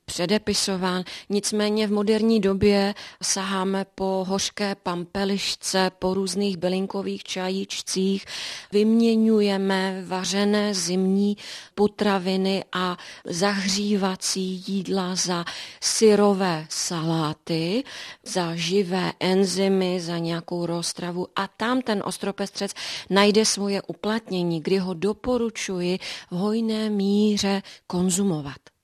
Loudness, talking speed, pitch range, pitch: -24 LUFS, 90 wpm, 185-205 Hz, 195 Hz